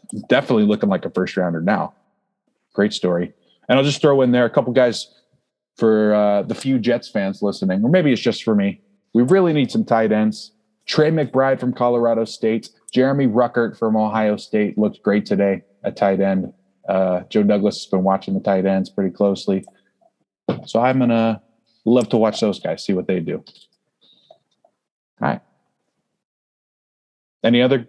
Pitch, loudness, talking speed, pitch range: 110 Hz, -19 LUFS, 170 wpm, 100-125 Hz